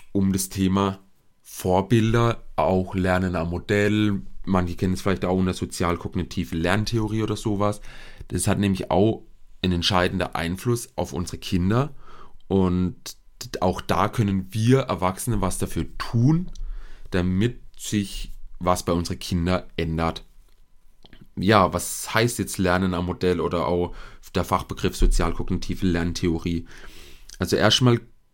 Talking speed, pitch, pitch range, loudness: 125 wpm, 95 Hz, 90-105 Hz, -24 LUFS